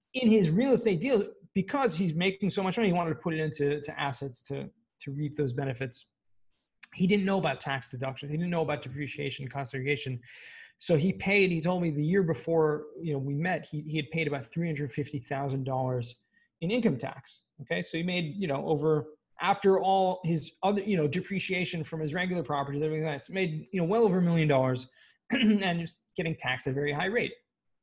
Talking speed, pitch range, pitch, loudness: 210 wpm, 140-185 Hz, 160 Hz, -29 LUFS